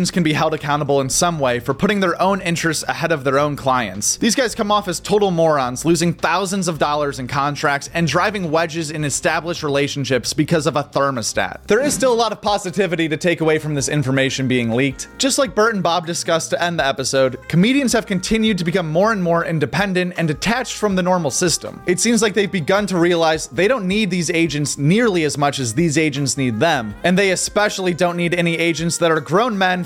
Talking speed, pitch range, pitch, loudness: 225 wpm, 145-190 Hz, 170 Hz, -18 LUFS